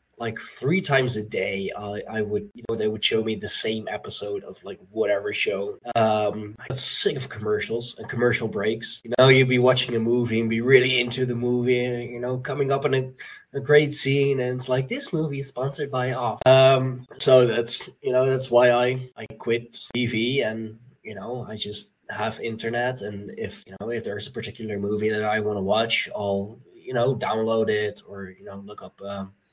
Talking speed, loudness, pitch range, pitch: 210 wpm, -23 LUFS, 110-130 Hz, 120 Hz